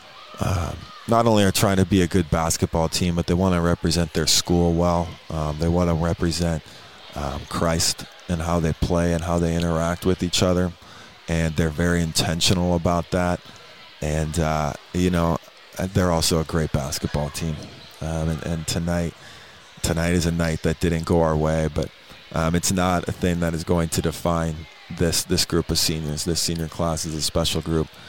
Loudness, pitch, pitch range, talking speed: -22 LUFS, 85 Hz, 80-90 Hz, 190 wpm